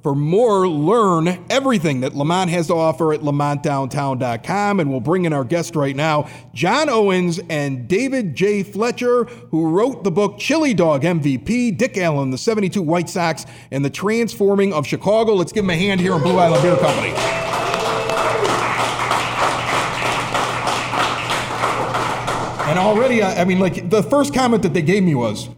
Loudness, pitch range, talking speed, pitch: -18 LUFS, 150-205 Hz, 155 wpm, 175 Hz